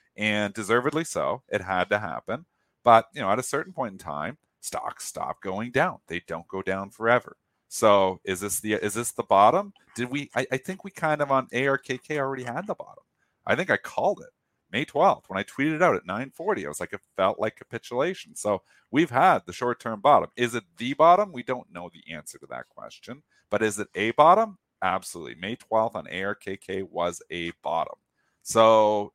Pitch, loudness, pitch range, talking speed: 115 Hz, -25 LUFS, 100-135 Hz, 210 wpm